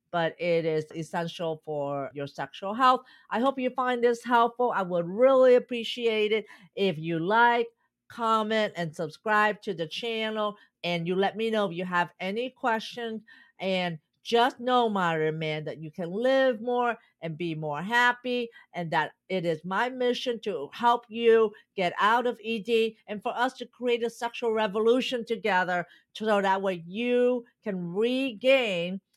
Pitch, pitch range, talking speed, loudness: 220 Hz, 175-240 Hz, 165 wpm, -27 LUFS